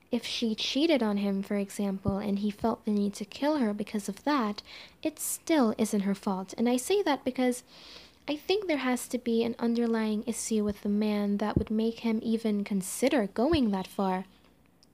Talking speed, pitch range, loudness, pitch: 195 wpm, 205-250 Hz, -29 LUFS, 225 Hz